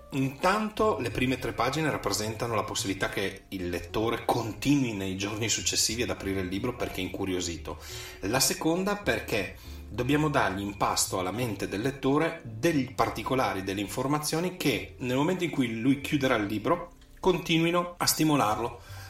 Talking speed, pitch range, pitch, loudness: 155 wpm, 100-145 Hz, 120 Hz, -28 LUFS